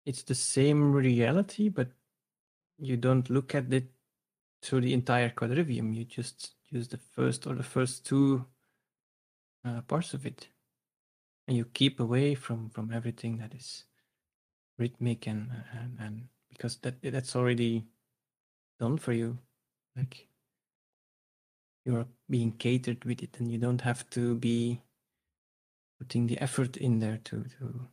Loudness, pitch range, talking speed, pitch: -31 LUFS, 115-130 Hz, 140 wpm, 120 Hz